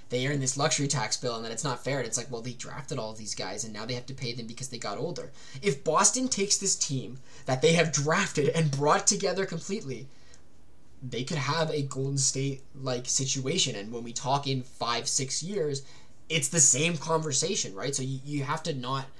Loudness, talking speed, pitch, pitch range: -28 LUFS, 220 wpm, 135 Hz, 125-160 Hz